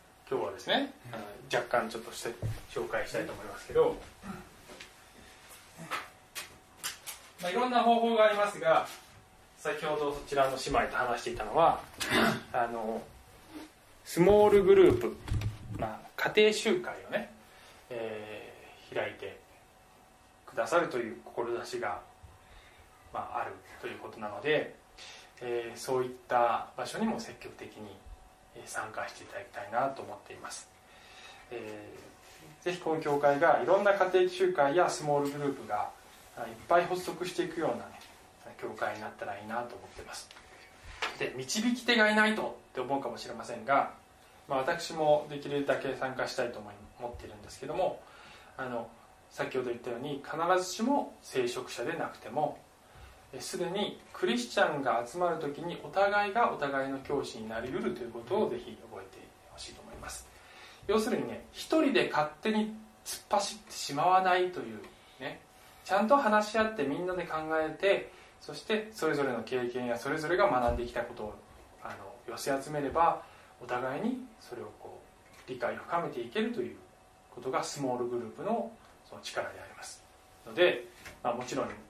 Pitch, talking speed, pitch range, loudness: 150 Hz, 320 characters per minute, 120-200 Hz, -31 LUFS